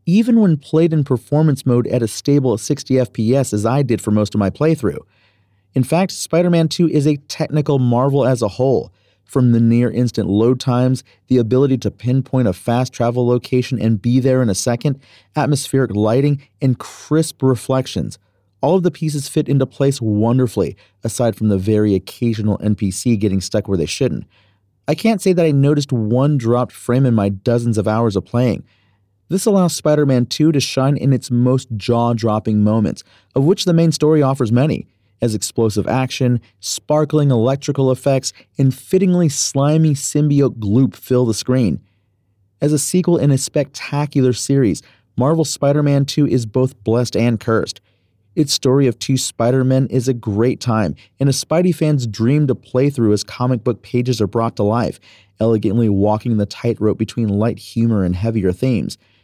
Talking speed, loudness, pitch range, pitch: 175 wpm, -17 LUFS, 110-140 Hz, 125 Hz